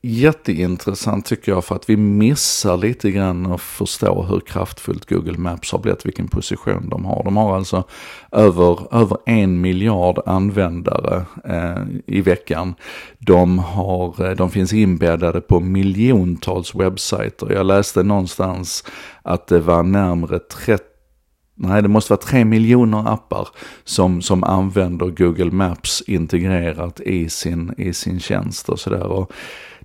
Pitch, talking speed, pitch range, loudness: 95 Hz, 140 wpm, 90-105 Hz, -18 LUFS